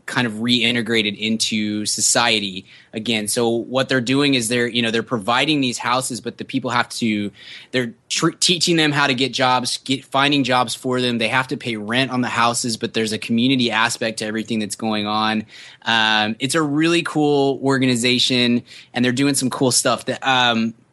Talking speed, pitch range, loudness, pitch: 195 wpm, 110-130 Hz, -18 LUFS, 120 Hz